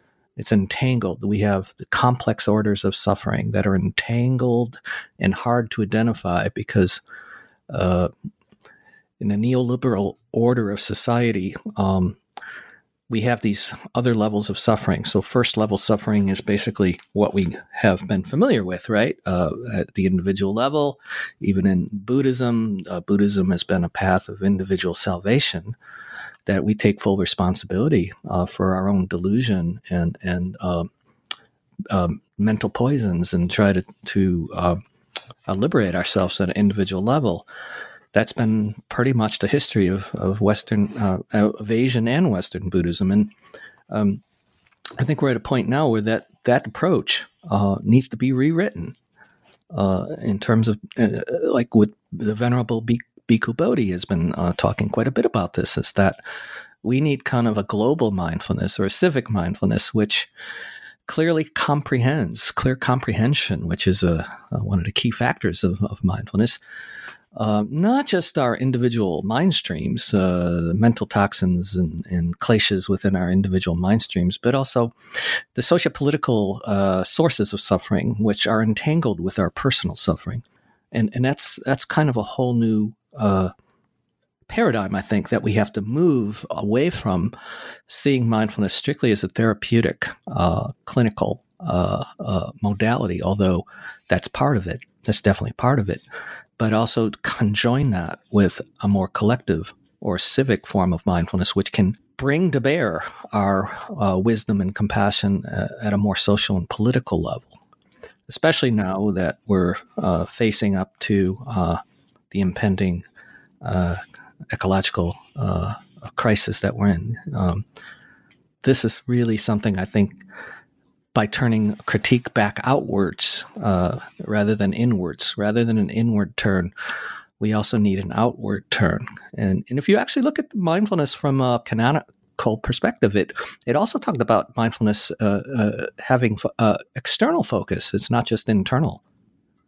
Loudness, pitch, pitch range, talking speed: -21 LUFS, 105 Hz, 95-120 Hz, 150 wpm